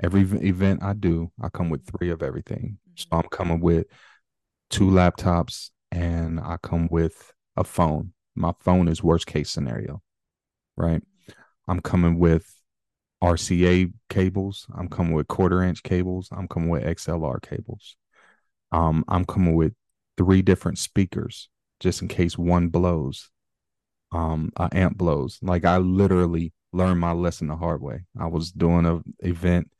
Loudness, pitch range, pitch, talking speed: -24 LUFS, 85-95 Hz, 90 Hz, 155 wpm